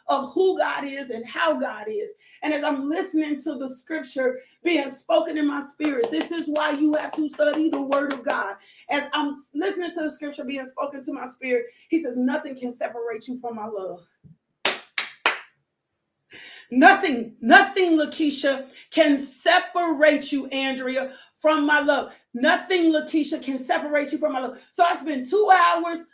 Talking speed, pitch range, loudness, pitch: 170 wpm, 270-325 Hz, -23 LUFS, 295 Hz